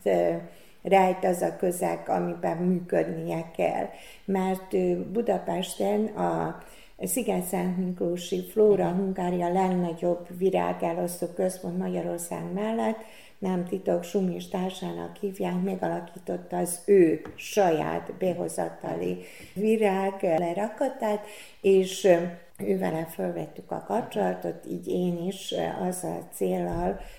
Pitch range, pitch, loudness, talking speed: 175-195 Hz, 185 Hz, -28 LUFS, 95 wpm